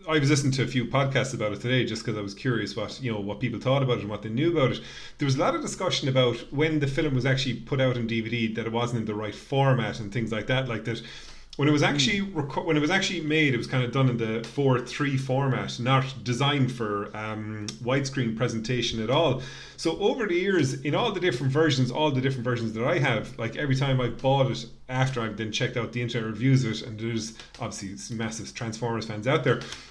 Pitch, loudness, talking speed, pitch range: 125 Hz, -26 LUFS, 255 wpm, 115-135 Hz